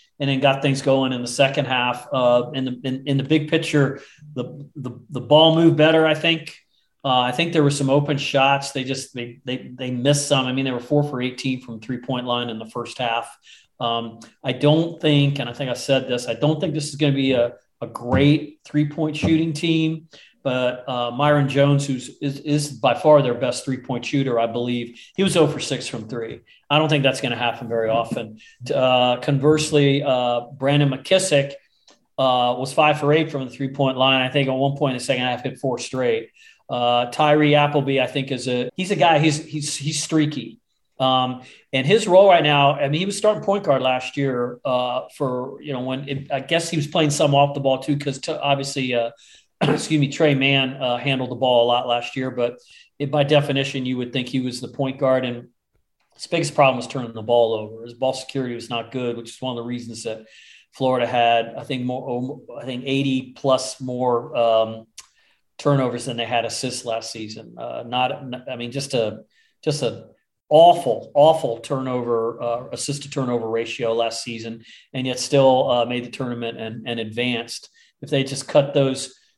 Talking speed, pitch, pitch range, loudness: 215 wpm, 130 Hz, 120-145 Hz, -21 LUFS